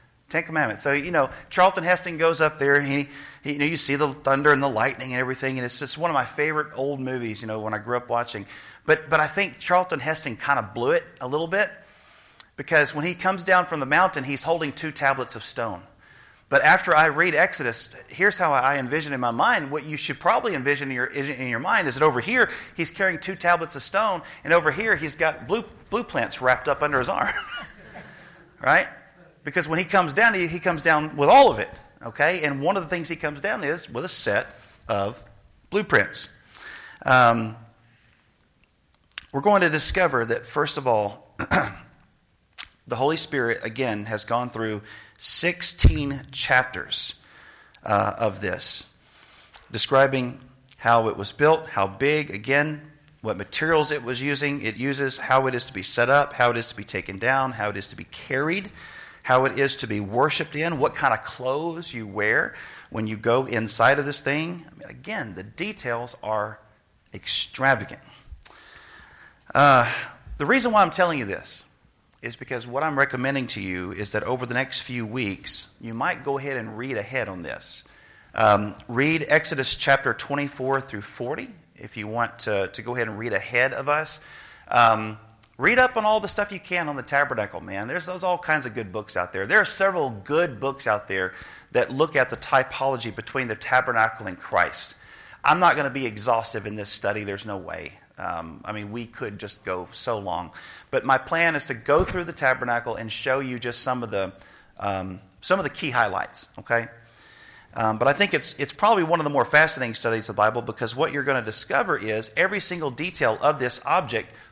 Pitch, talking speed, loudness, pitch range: 135 Hz, 205 wpm, -23 LUFS, 115-155 Hz